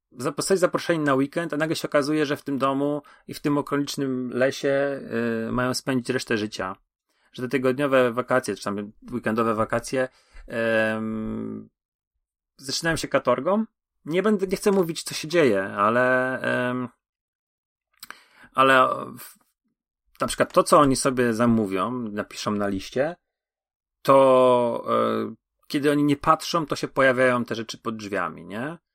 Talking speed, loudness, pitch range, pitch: 145 wpm, -23 LUFS, 115-145 Hz, 130 Hz